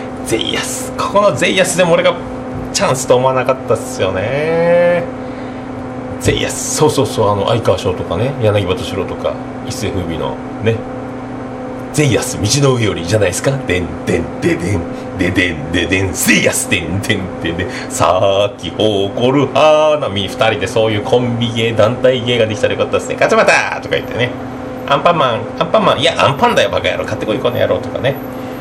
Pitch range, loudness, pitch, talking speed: 110-135 Hz, -14 LUFS, 130 Hz, 385 characters per minute